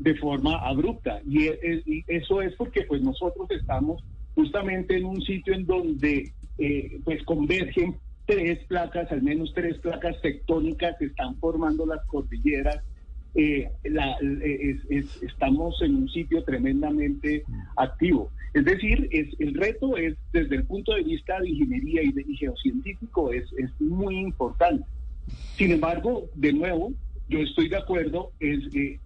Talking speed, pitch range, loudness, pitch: 150 wpm, 145-195 Hz, -26 LUFS, 165 Hz